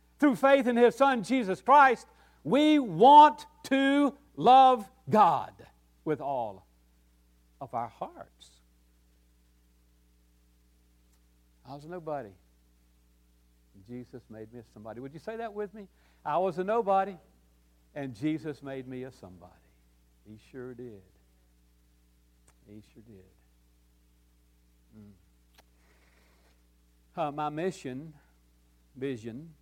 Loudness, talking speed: -25 LUFS, 110 wpm